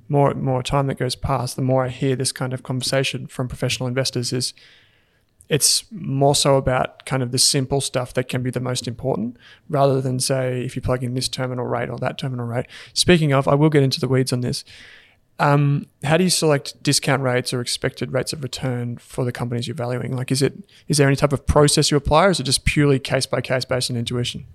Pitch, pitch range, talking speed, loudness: 130 Hz, 125-140 Hz, 235 wpm, -20 LUFS